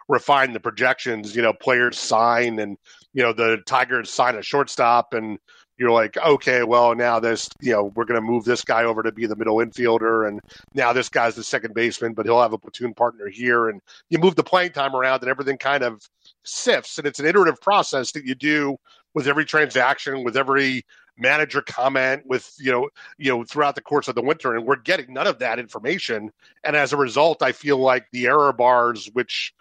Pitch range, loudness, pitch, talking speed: 115-140 Hz, -20 LUFS, 120 Hz, 215 wpm